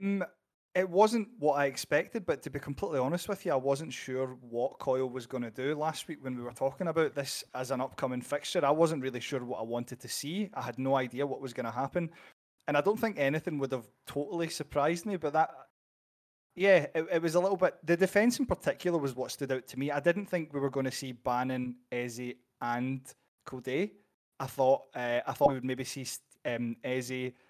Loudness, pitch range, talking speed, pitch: -32 LUFS, 130-165 Hz, 225 wpm, 135 Hz